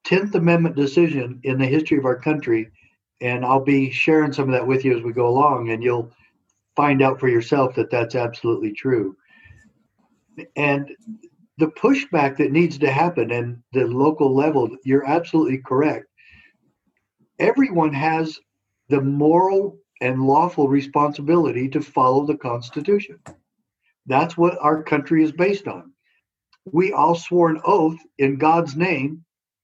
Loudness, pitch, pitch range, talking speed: -20 LUFS, 145 Hz, 130-160 Hz, 145 wpm